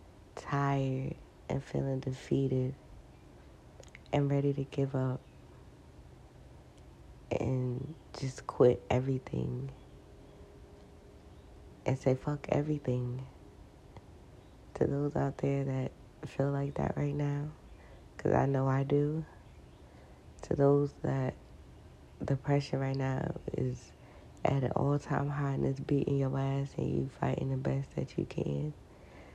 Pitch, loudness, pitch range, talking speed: 135 Hz, -33 LUFS, 125-140 Hz, 115 wpm